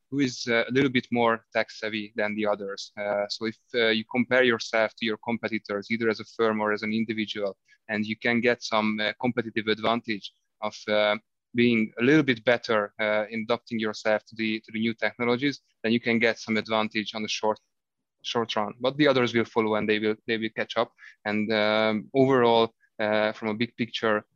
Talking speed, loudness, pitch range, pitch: 210 wpm, -26 LUFS, 105-120 Hz, 110 Hz